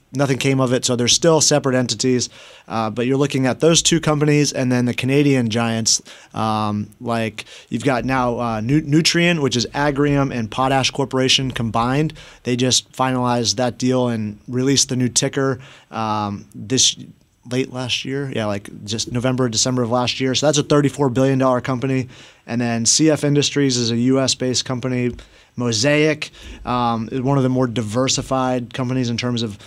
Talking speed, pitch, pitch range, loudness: 175 wpm, 130 Hz, 120-135 Hz, -18 LUFS